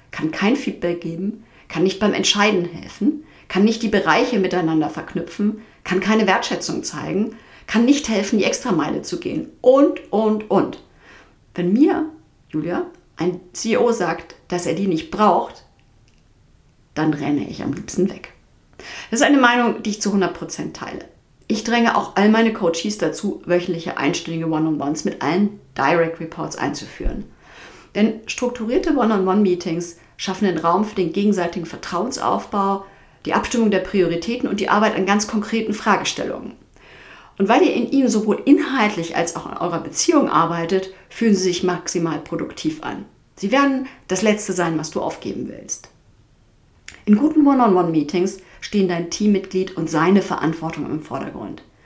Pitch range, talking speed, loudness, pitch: 175-225 Hz, 150 wpm, -20 LUFS, 195 Hz